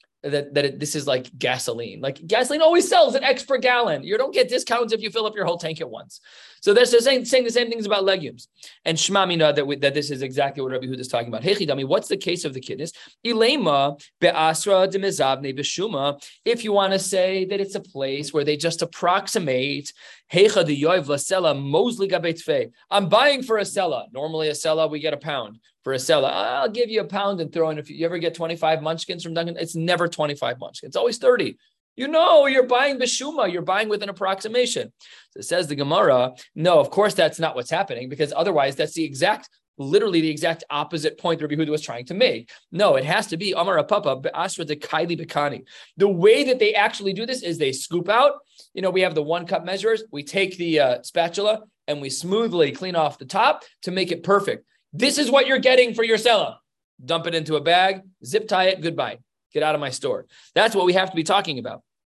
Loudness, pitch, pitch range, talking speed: -21 LUFS, 180 Hz, 150-220 Hz, 215 wpm